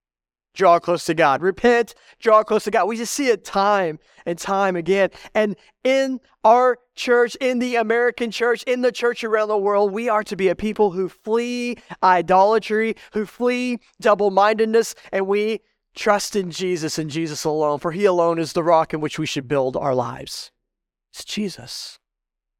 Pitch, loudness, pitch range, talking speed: 205 Hz, -20 LUFS, 170-230 Hz, 180 wpm